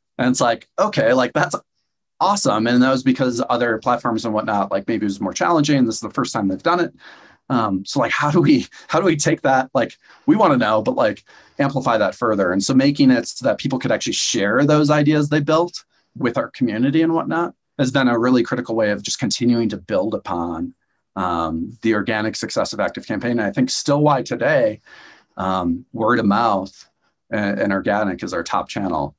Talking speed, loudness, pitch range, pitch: 215 wpm, -19 LUFS, 110-140 Hz, 120 Hz